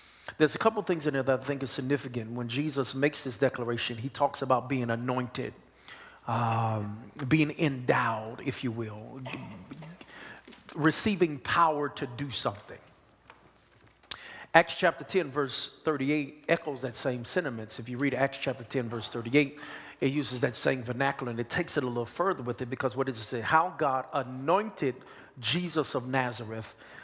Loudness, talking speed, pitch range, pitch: -30 LUFS, 165 wpm, 120-150 Hz, 135 Hz